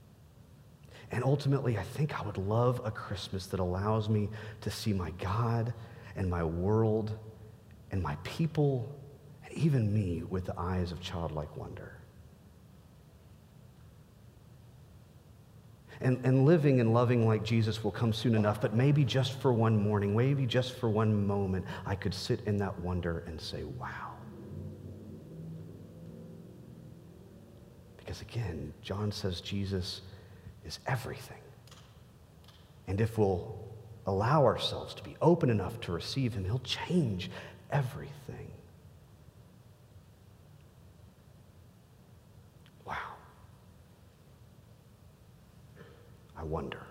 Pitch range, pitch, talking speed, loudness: 95-125 Hz, 110 Hz, 110 wpm, -32 LUFS